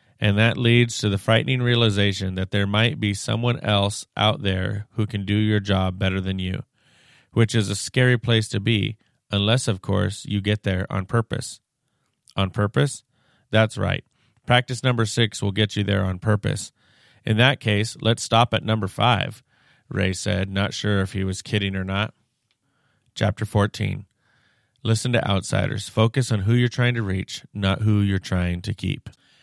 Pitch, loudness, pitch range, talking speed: 110 Hz, -22 LUFS, 100-120 Hz, 175 wpm